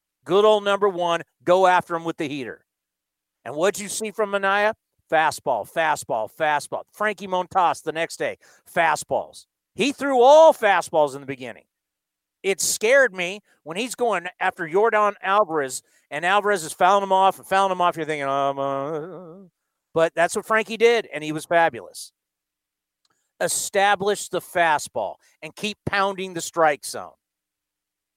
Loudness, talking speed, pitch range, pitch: -21 LUFS, 155 wpm, 150-205 Hz, 180 Hz